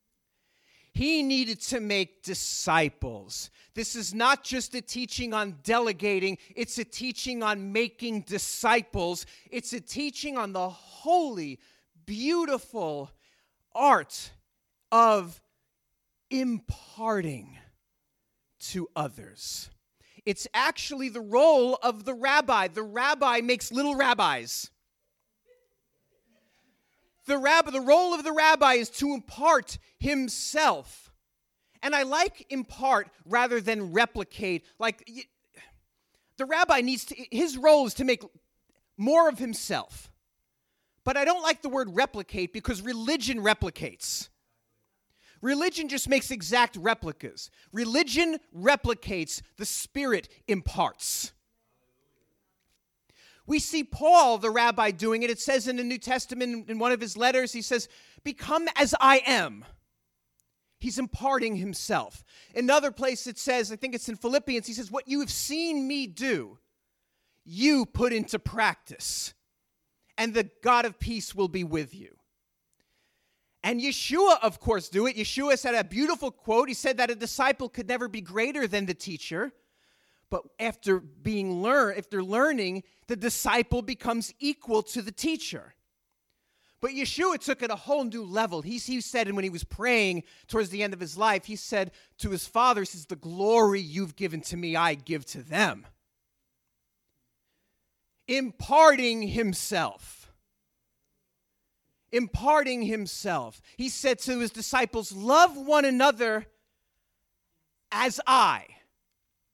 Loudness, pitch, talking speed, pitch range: -27 LUFS, 235 Hz, 130 wpm, 205-270 Hz